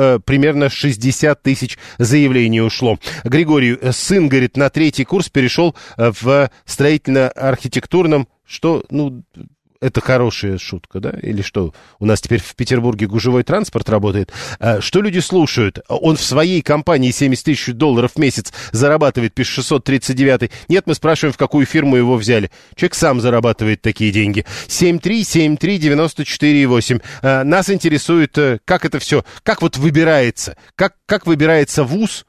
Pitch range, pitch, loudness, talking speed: 120-155 Hz, 135 Hz, -15 LUFS, 130 wpm